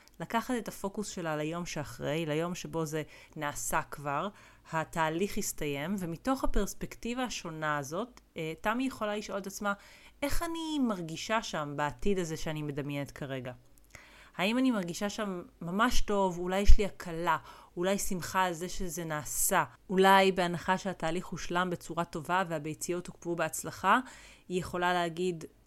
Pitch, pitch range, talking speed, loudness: 180 Hz, 160-200 Hz, 140 wpm, -33 LUFS